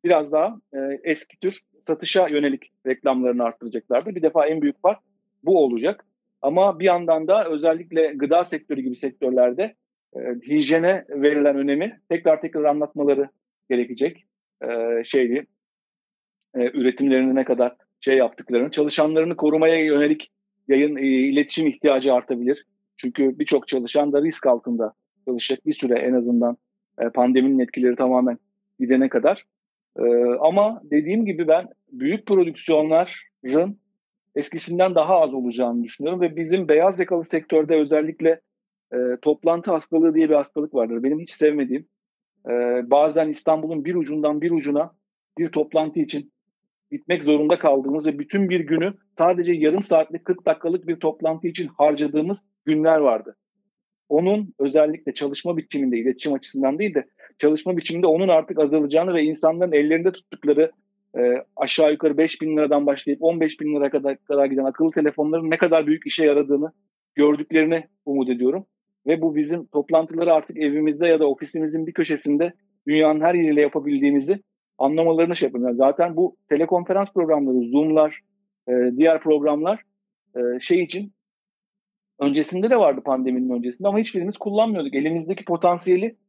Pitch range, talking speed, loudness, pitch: 140-185 Hz, 140 wpm, -21 LUFS, 155 Hz